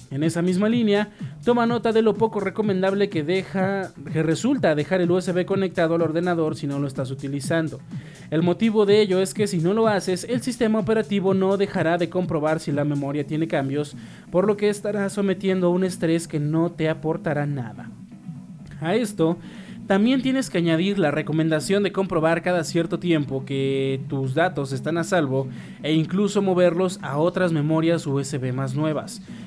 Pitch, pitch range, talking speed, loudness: 175 Hz, 155-195 Hz, 180 wpm, -22 LUFS